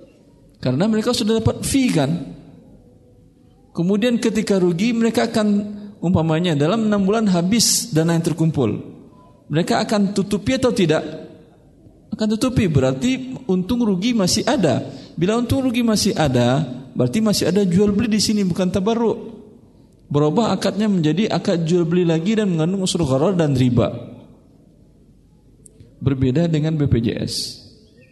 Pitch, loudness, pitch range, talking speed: 190 Hz, -19 LUFS, 155-220 Hz, 130 wpm